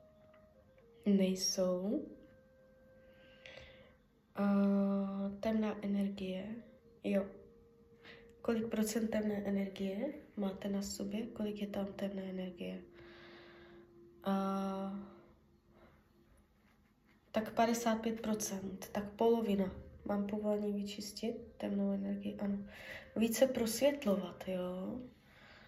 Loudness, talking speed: -37 LUFS, 70 wpm